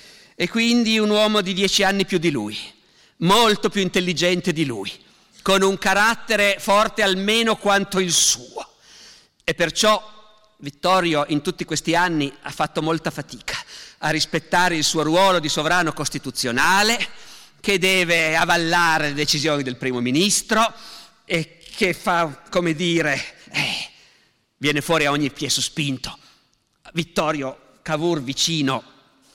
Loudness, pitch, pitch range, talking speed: -20 LUFS, 170 Hz, 150-195 Hz, 135 wpm